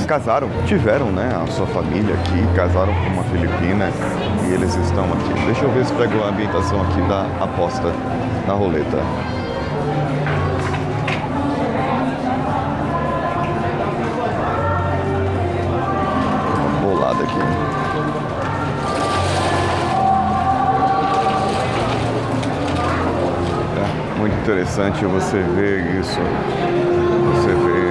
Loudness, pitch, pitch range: -19 LUFS, 95 Hz, 90-105 Hz